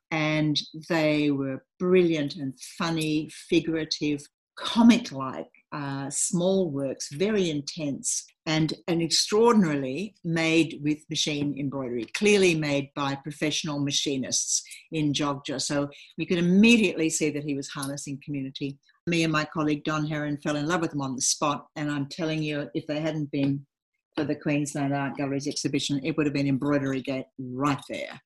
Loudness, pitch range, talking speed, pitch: -26 LUFS, 140-160 Hz, 155 wpm, 150 Hz